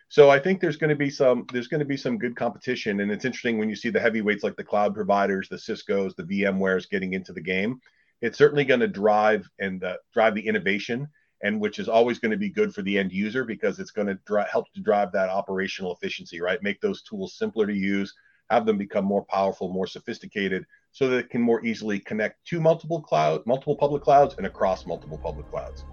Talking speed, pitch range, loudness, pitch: 230 wpm, 100-145 Hz, -25 LUFS, 115 Hz